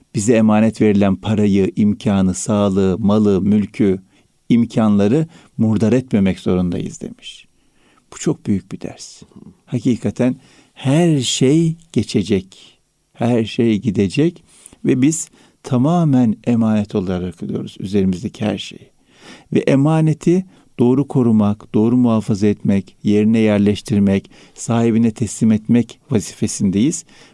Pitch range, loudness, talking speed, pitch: 105-125 Hz, -17 LUFS, 105 wpm, 110 Hz